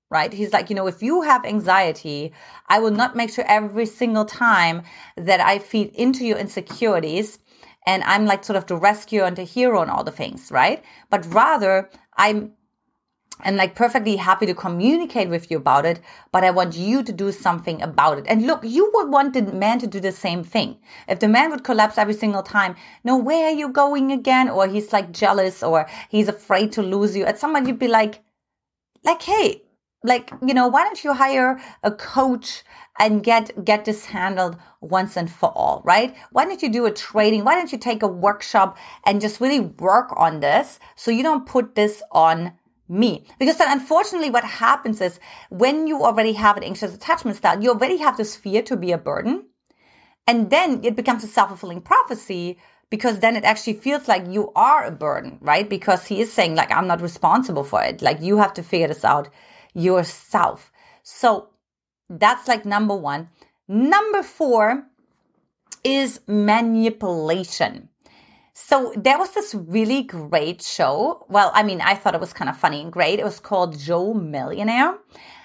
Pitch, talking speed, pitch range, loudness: 215 Hz, 190 wpm, 190-250 Hz, -19 LUFS